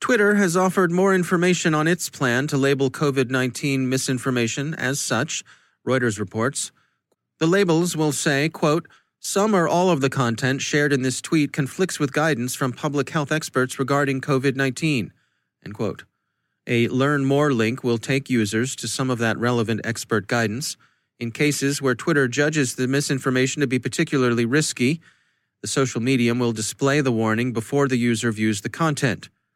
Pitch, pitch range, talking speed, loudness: 135 Hz, 120-150 Hz, 165 wpm, -21 LUFS